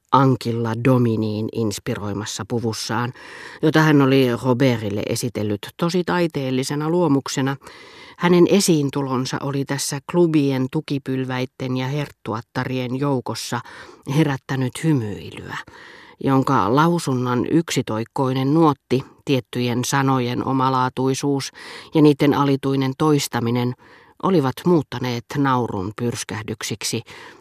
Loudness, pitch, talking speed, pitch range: -20 LUFS, 130 Hz, 85 wpm, 120-145 Hz